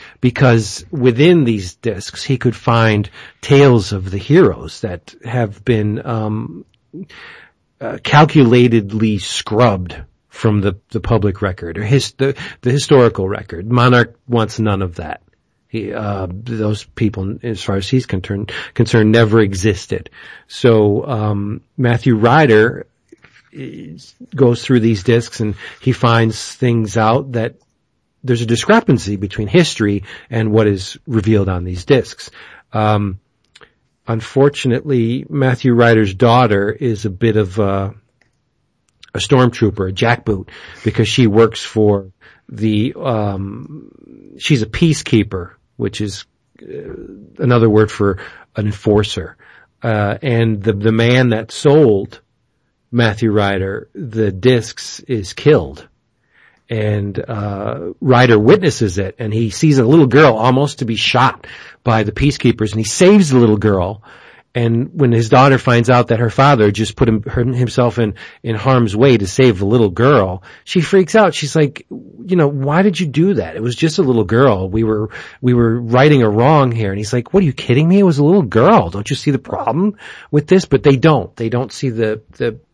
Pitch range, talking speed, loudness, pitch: 105-130 Hz, 155 wpm, -14 LUFS, 115 Hz